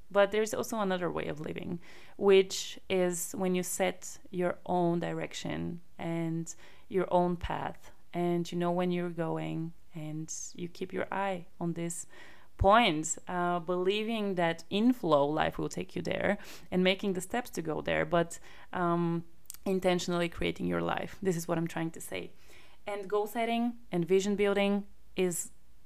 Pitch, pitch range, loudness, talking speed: 180 Hz, 170-195 Hz, -32 LUFS, 160 wpm